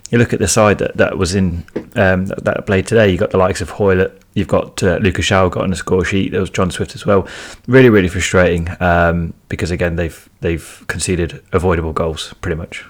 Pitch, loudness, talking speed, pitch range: 95 Hz, -15 LUFS, 230 wpm, 85-100 Hz